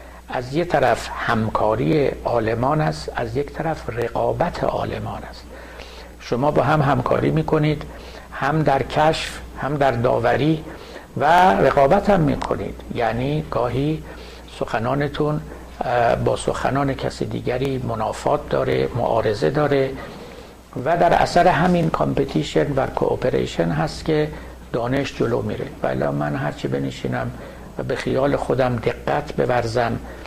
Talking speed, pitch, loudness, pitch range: 125 wpm, 135 Hz, -21 LUFS, 110-150 Hz